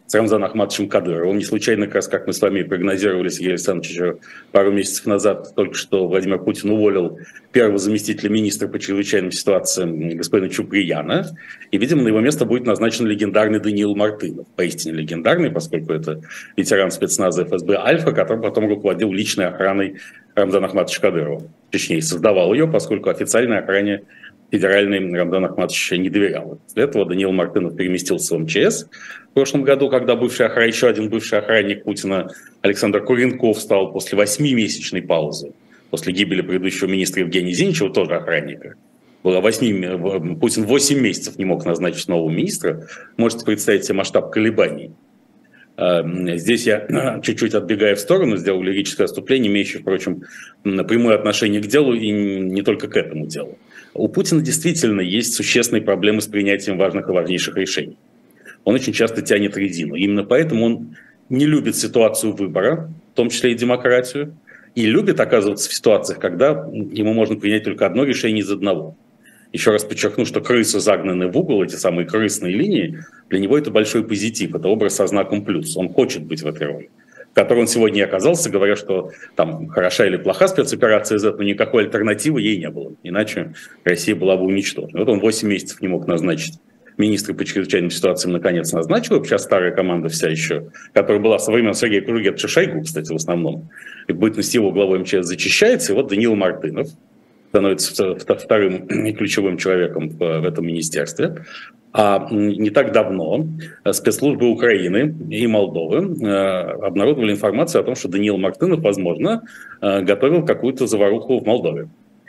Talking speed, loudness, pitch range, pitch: 160 wpm, -18 LUFS, 95-115 Hz, 100 Hz